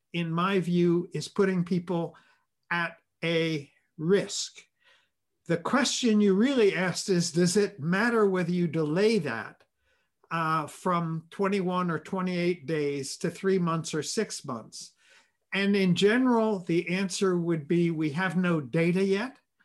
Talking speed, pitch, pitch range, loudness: 140 wpm, 180 Hz, 165-195 Hz, -27 LUFS